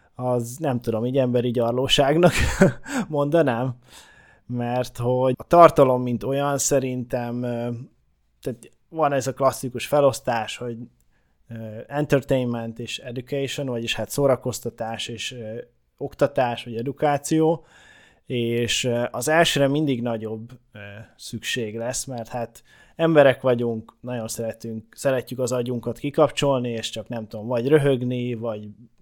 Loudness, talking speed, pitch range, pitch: -23 LUFS, 115 wpm, 115-140 Hz, 125 Hz